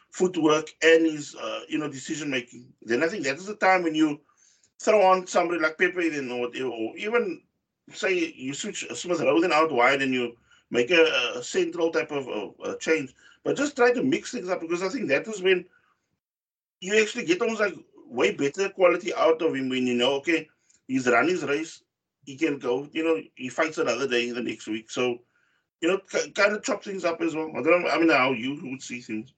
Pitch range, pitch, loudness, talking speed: 135-200 Hz, 160 Hz, -25 LUFS, 220 wpm